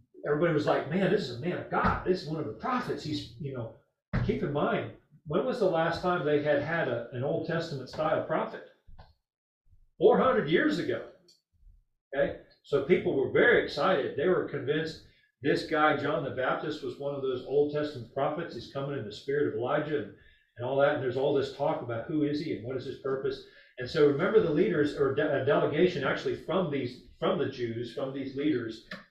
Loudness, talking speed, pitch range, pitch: -29 LUFS, 210 wpm, 135-180 Hz, 150 Hz